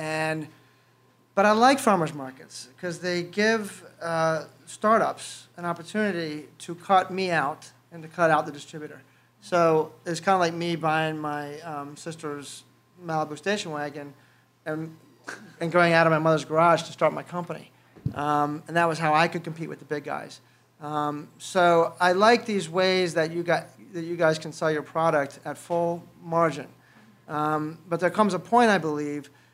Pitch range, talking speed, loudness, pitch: 150-175 Hz, 175 wpm, -25 LUFS, 160 Hz